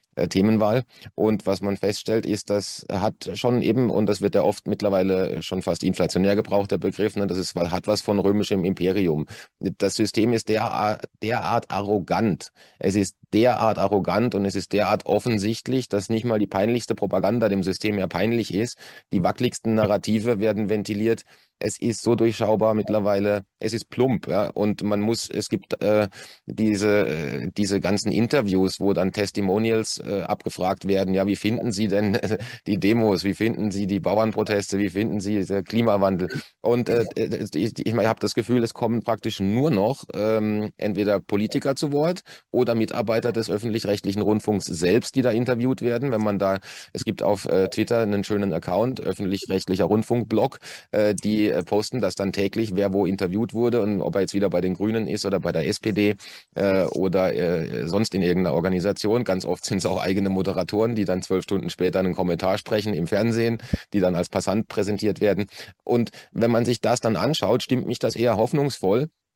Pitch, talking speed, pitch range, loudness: 105 Hz, 185 wpm, 100-110 Hz, -23 LUFS